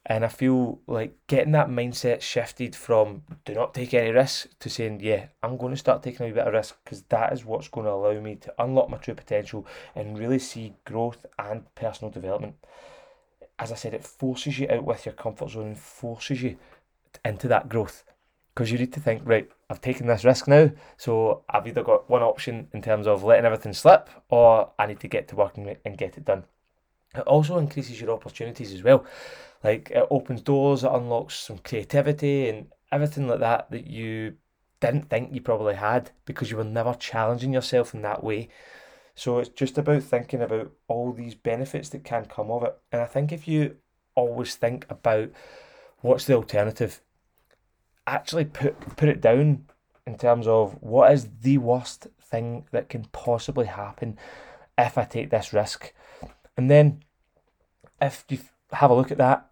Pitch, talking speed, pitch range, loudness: 125 Hz, 190 wpm, 115-140 Hz, -24 LUFS